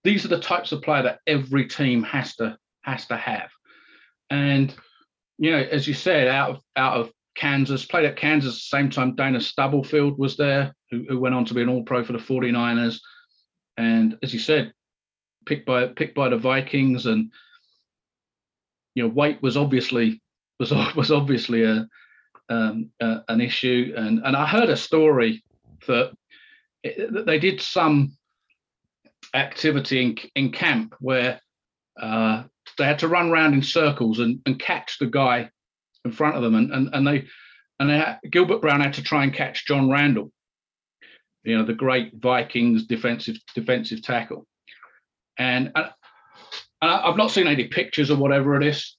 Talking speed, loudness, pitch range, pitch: 170 wpm, -22 LUFS, 120-150 Hz, 135 Hz